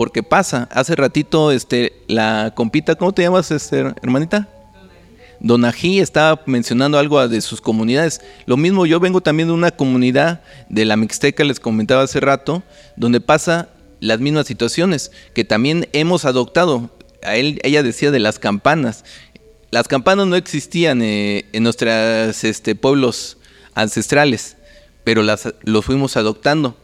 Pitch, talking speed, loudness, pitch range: 130 Hz, 145 wpm, -16 LUFS, 115-155 Hz